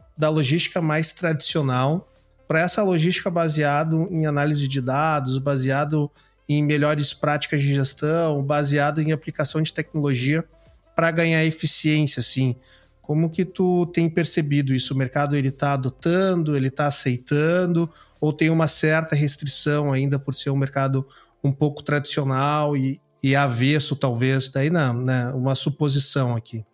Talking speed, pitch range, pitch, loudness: 145 wpm, 135-160 Hz, 145 Hz, -22 LUFS